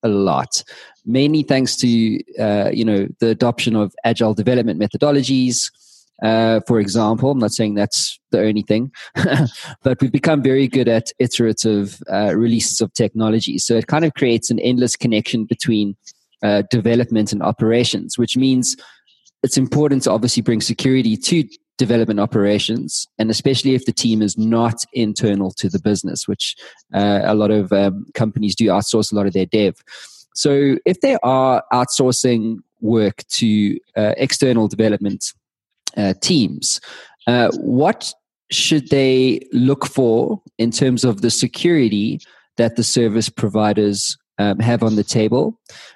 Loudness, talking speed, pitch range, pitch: -17 LUFS, 150 wpm, 105-130 Hz, 115 Hz